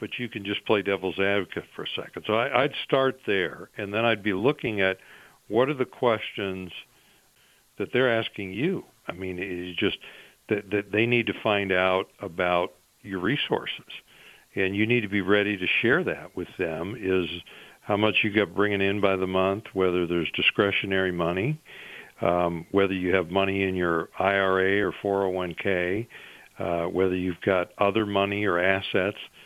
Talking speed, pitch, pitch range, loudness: 180 wpm, 95 Hz, 90-105 Hz, -26 LUFS